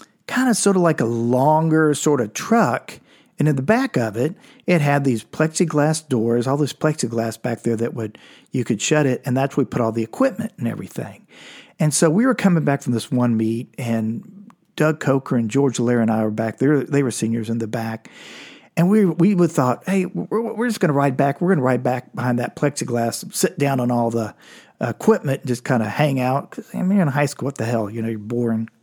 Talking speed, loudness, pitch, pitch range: 245 wpm, -20 LUFS, 140 Hz, 120-170 Hz